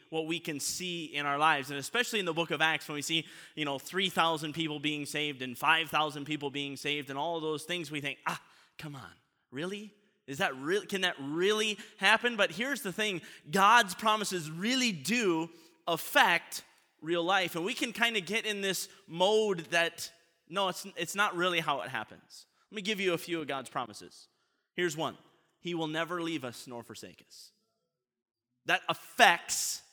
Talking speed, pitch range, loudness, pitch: 190 wpm, 150-195 Hz, -31 LUFS, 170 Hz